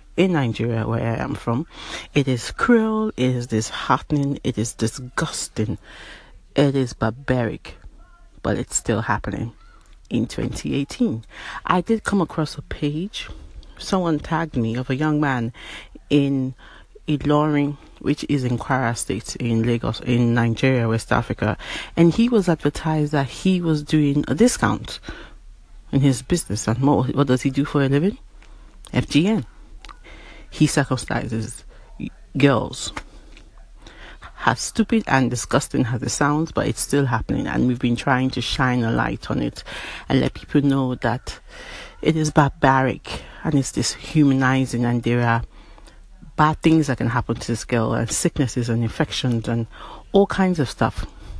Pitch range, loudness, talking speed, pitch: 115-150 Hz, -21 LUFS, 150 wpm, 130 Hz